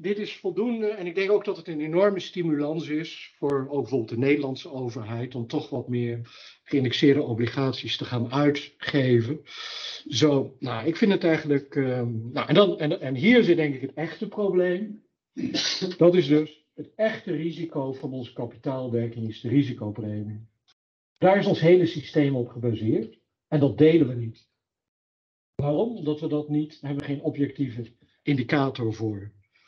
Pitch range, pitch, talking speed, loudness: 125-165 Hz, 145 Hz, 170 wpm, -25 LUFS